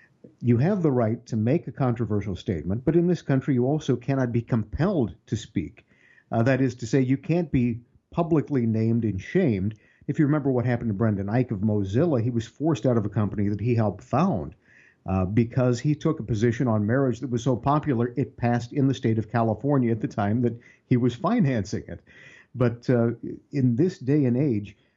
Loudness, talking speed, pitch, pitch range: -25 LUFS, 210 wpm, 120 Hz, 115-140 Hz